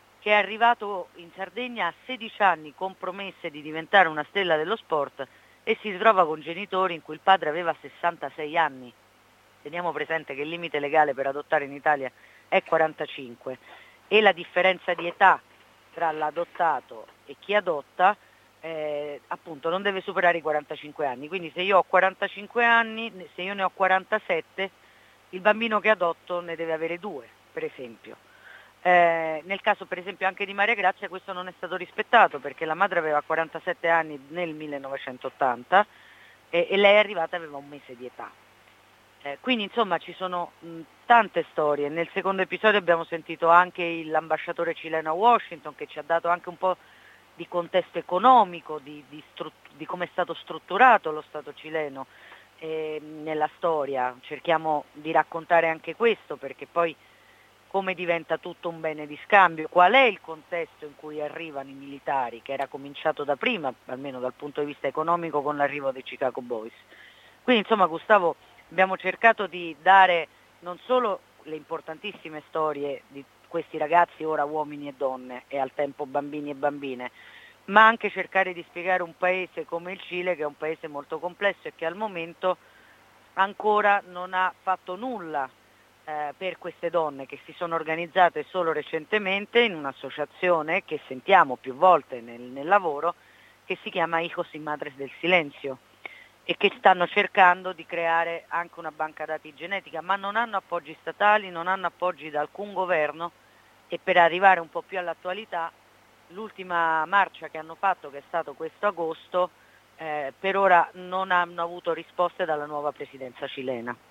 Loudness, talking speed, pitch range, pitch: -25 LUFS, 170 wpm, 150-185 Hz, 165 Hz